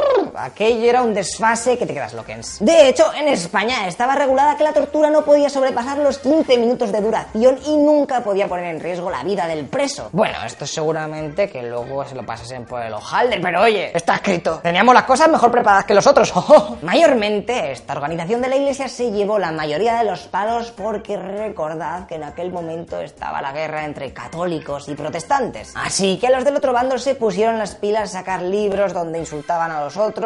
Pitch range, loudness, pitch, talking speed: 170-260 Hz, -18 LUFS, 215 Hz, 205 wpm